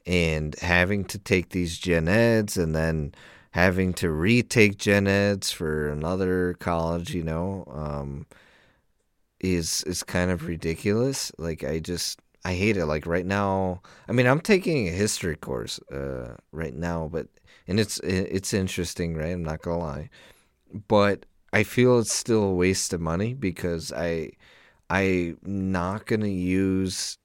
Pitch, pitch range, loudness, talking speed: 90 Hz, 85-100 Hz, -25 LUFS, 150 wpm